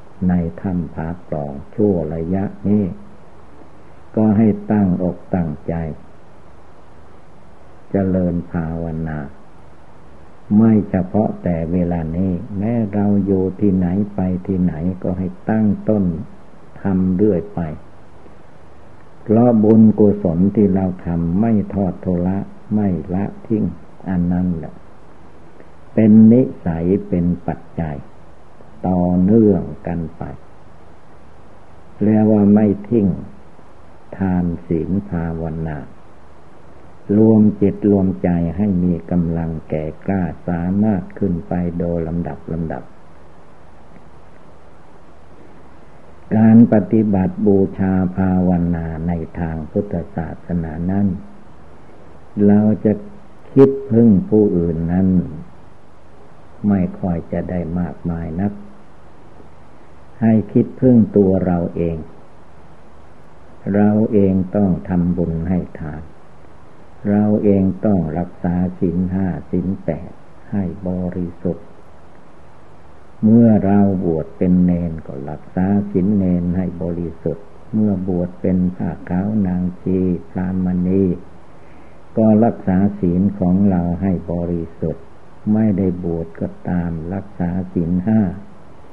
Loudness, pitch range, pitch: -18 LUFS, 85-100 Hz, 90 Hz